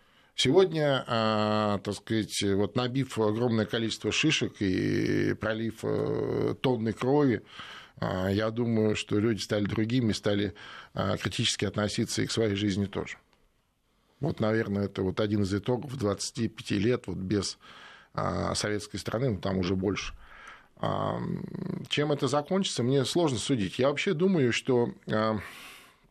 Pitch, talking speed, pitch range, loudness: 110 Hz, 120 wpm, 105-130 Hz, -29 LUFS